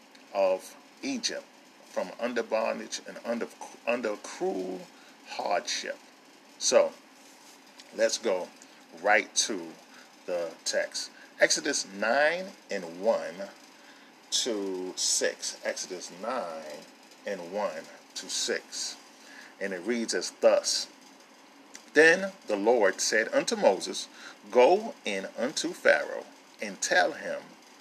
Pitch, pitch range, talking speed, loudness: 280 Hz, 270-290 Hz, 100 wpm, -28 LUFS